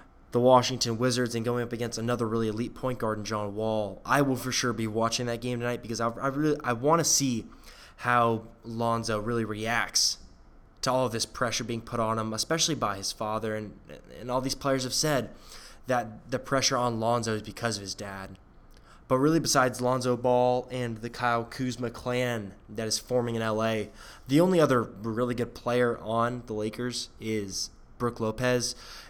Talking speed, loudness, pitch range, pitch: 190 wpm, -28 LUFS, 110-125 Hz, 120 Hz